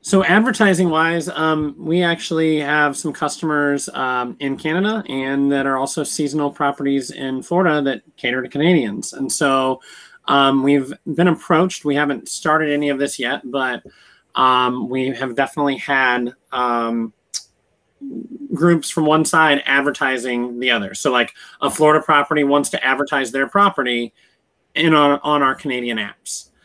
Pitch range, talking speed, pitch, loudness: 135-160 Hz, 150 wpm, 145 Hz, -18 LUFS